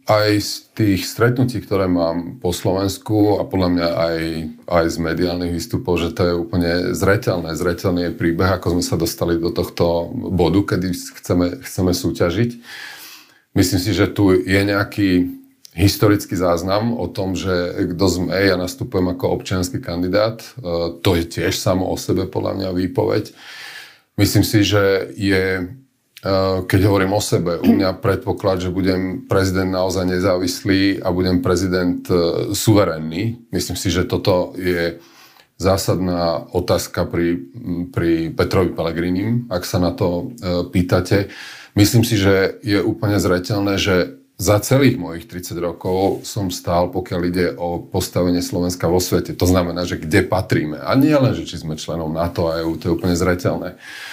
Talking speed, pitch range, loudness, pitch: 155 wpm, 90-100 Hz, -19 LUFS, 90 Hz